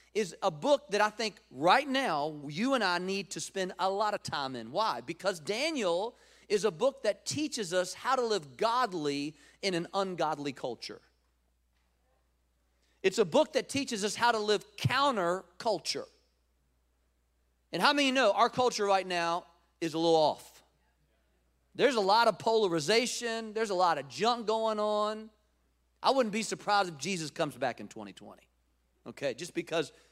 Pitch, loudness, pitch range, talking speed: 190 Hz, -31 LUFS, 140-220 Hz, 165 wpm